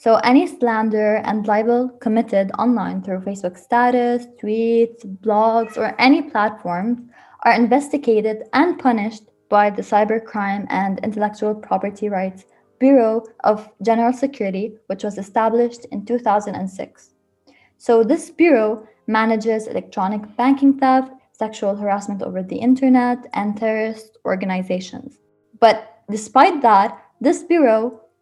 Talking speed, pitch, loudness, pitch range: 115 wpm, 220 Hz, -18 LUFS, 210-245 Hz